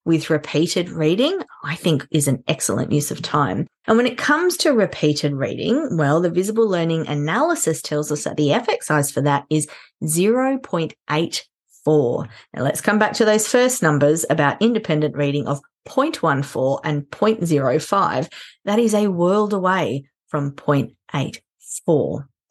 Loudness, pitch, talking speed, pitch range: -20 LUFS, 160 Hz, 145 wpm, 145-210 Hz